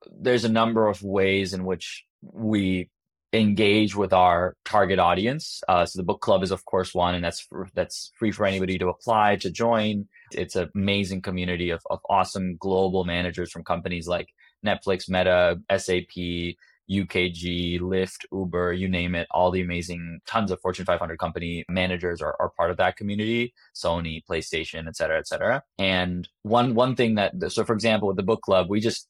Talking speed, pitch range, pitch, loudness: 185 wpm, 90-105 Hz, 95 Hz, -25 LUFS